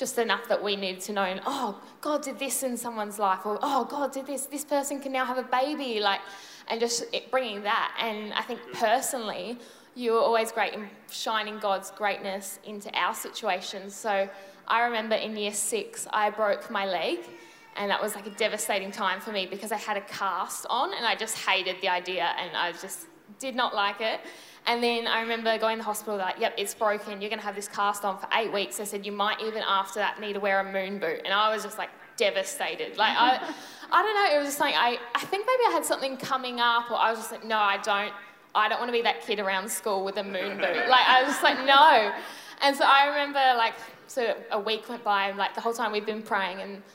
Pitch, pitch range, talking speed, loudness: 215 Hz, 200-250 Hz, 240 wpm, -27 LUFS